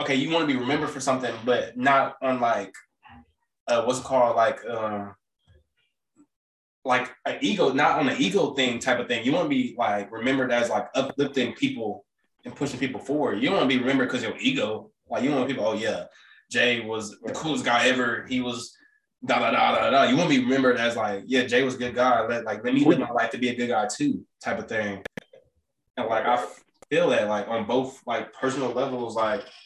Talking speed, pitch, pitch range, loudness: 225 wpm, 130 Hz, 120-140 Hz, -24 LUFS